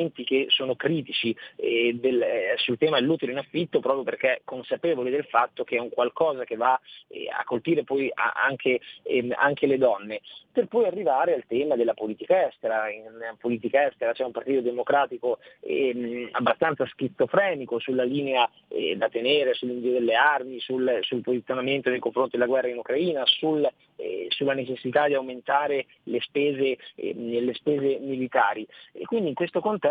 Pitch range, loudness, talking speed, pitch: 125-160 Hz, -25 LUFS, 155 wpm, 130 Hz